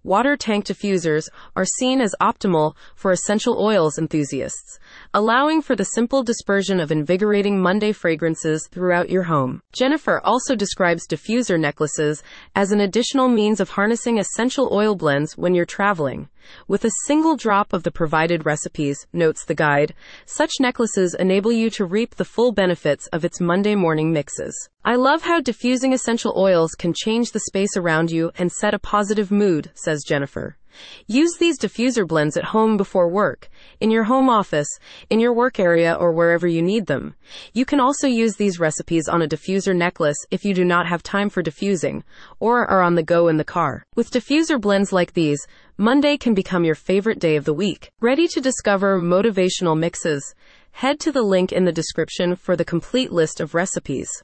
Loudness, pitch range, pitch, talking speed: -20 LUFS, 170-230 Hz, 190 Hz, 180 wpm